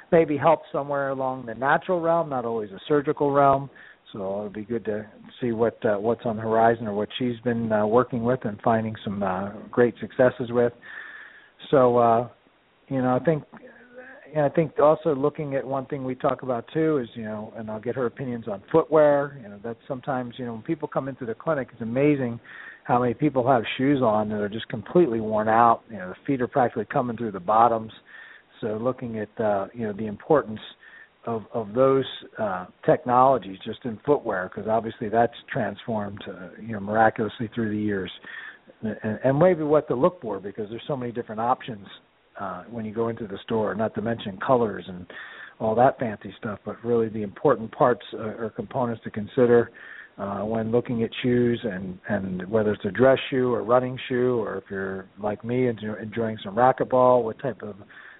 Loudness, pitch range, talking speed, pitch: -25 LUFS, 110-135 Hz, 200 wpm, 120 Hz